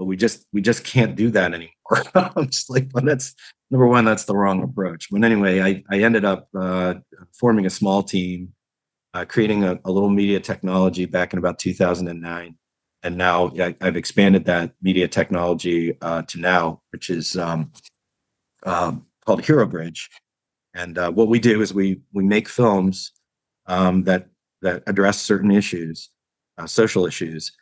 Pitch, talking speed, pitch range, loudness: 95 Hz, 170 wpm, 90-110 Hz, -20 LUFS